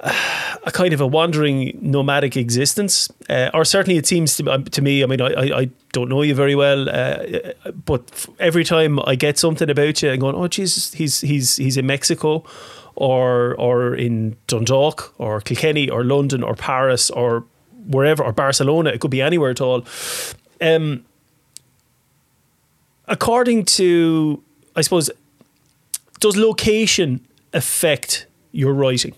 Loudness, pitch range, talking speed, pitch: -18 LUFS, 130-165 Hz, 150 wpm, 140 Hz